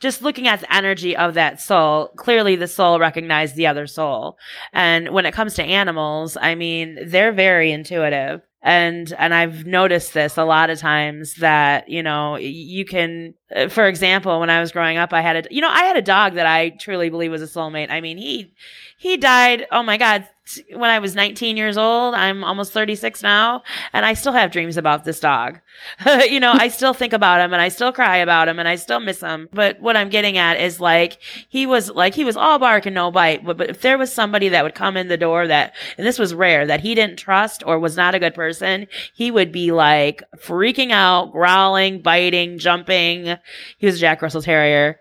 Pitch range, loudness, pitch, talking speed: 165-210 Hz, -16 LUFS, 175 Hz, 220 wpm